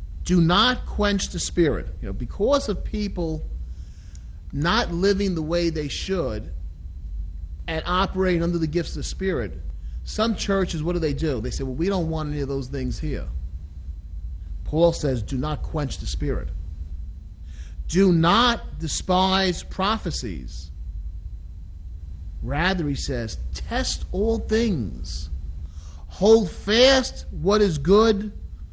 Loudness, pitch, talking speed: -23 LUFS, 140 Hz, 130 wpm